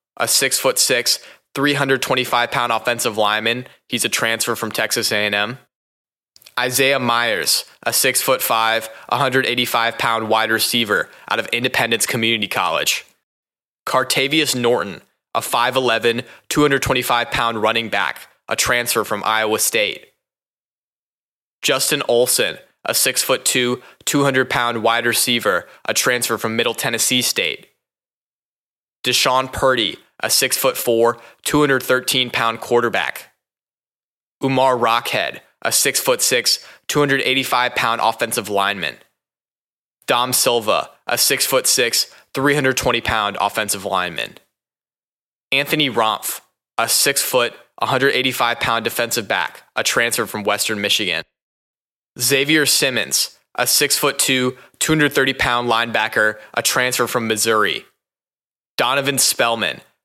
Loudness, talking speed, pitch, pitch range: -17 LUFS, 120 wpm, 120 Hz, 115-135 Hz